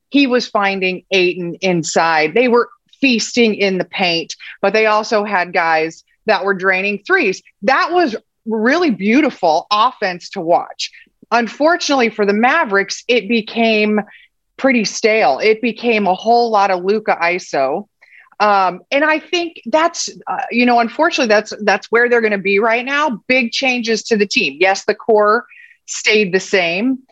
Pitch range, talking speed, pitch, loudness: 195-250 Hz, 160 wpm, 220 Hz, -15 LUFS